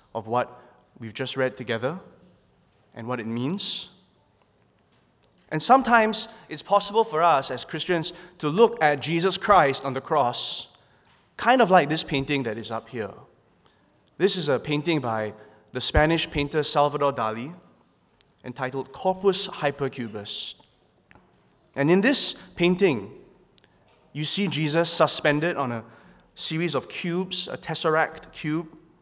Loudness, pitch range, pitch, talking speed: -24 LUFS, 125-175 Hz, 150 Hz, 130 wpm